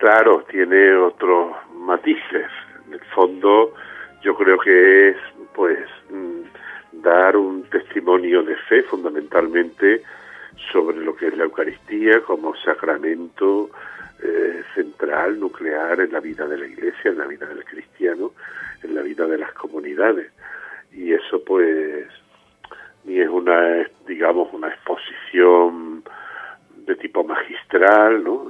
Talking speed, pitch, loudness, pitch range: 125 wpm, 375 Hz, -18 LUFS, 320-405 Hz